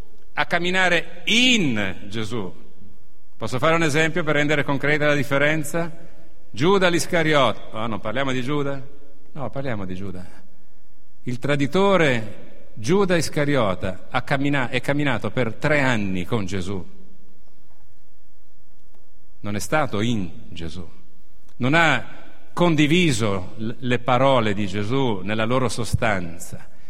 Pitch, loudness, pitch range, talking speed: 130 Hz, -21 LUFS, 105-150 Hz, 110 wpm